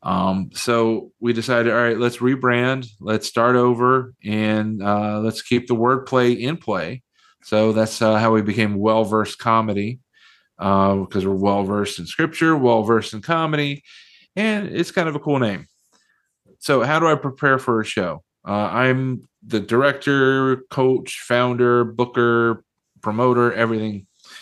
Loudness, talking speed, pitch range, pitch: -19 LUFS, 145 wpm, 110-130 Hz, 120 Hz